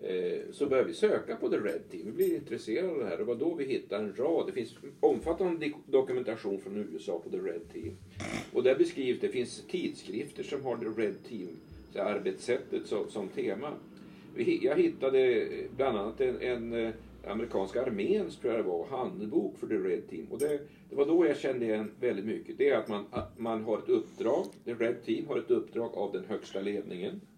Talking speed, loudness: 190 wpm, -32 LUFS